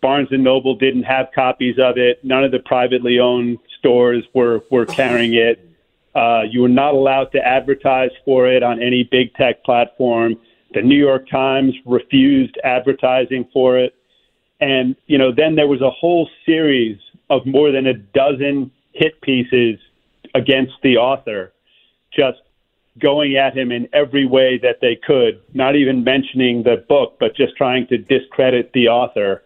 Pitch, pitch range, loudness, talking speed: 130 Hz, 125-135 Hz, -15 LUFS, 165 wpm